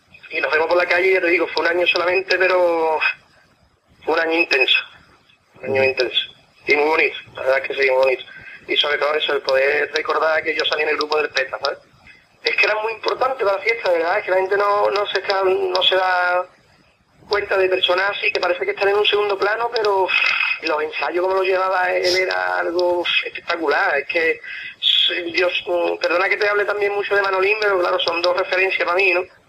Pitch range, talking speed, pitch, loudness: 170-205 Hz, 220 wpm, 185 Hz, -18 LUFS